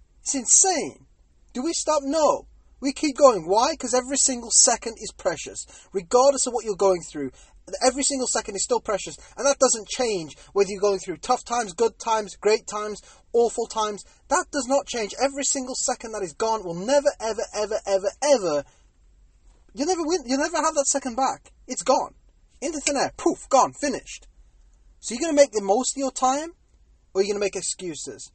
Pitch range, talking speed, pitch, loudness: 200-275 Hz, 195 wpm, 240 Hz, -23 LUFS